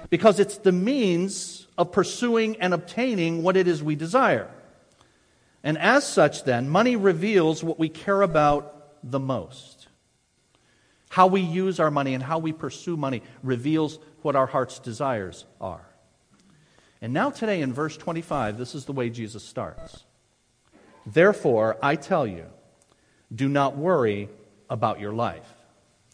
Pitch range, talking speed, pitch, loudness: 130-185 Hz, 145 wpm, 155 Hz, -24 LUFS